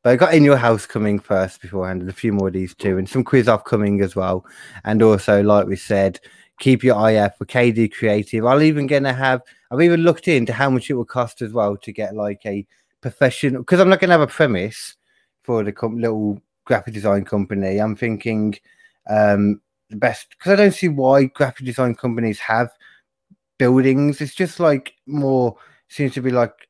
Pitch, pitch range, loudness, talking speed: 120 Hz, 105-135 Hz, -18 LUFS, 210 wpm